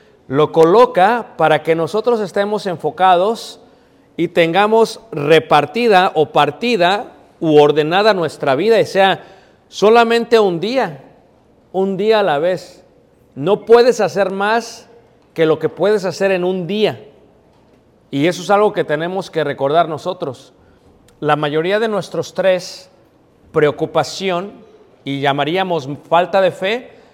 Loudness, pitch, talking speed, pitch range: -15 LUFS, 180 Hz, 130 wpm, 155-205 Hz